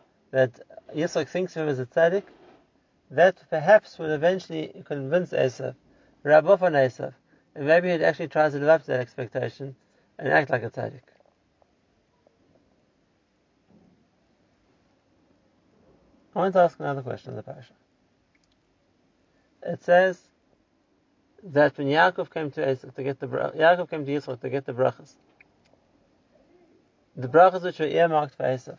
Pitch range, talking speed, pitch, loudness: 135-175 Hz, 135 wpm, 155 Hz, -24 LUFS